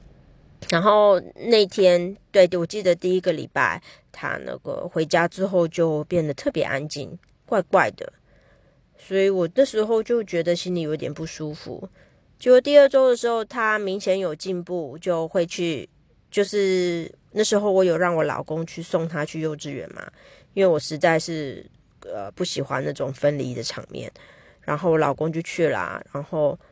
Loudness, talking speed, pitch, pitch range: -22 LUFS, 245 characters per minute, 175 Hz, 160-200 Hz